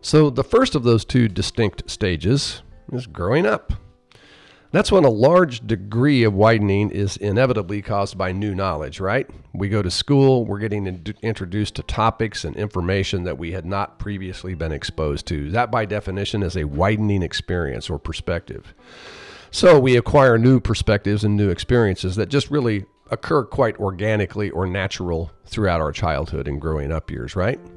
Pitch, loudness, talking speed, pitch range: 100 Hz, -20 LUFS, 170 wpm, 90-115 Hz